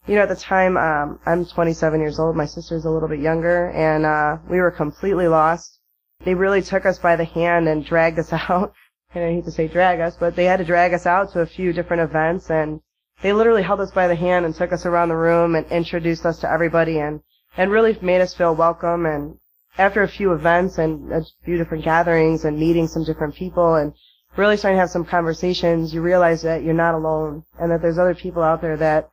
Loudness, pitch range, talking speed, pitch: -19 LUFS, 160-180 Hz, 235 wpm, 170 Hz